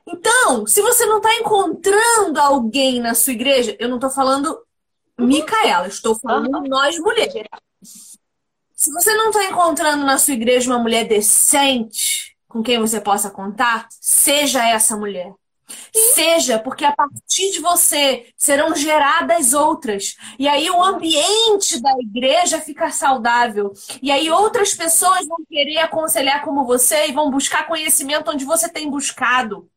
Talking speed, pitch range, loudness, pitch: 145 wpm, 245-335 Hz, -15 LUFS, 290 Hz